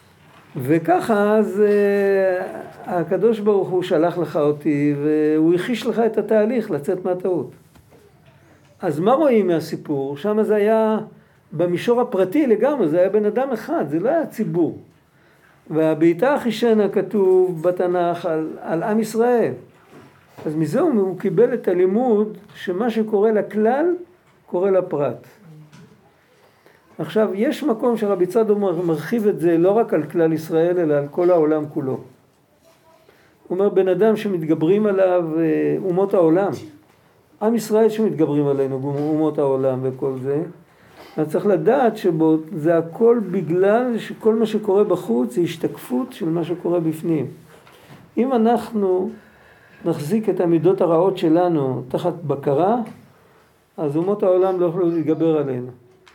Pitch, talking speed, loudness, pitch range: 185 Hz, 125 wpm, -19 LUFS, 160-215 Hz